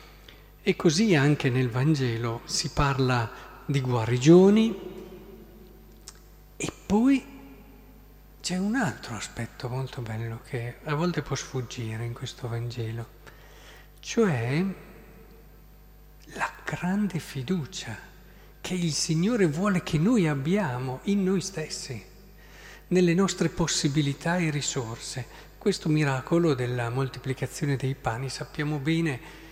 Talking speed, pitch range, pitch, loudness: 105 wpm, 130-185 Hz, 150 Hz, -27 LUFS